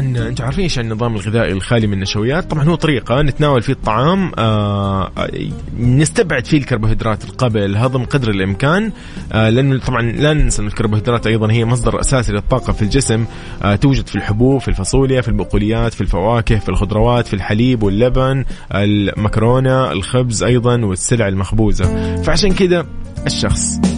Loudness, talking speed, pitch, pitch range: -15 LUFS, 140 wpm, 115 Hz, 105-130 Hz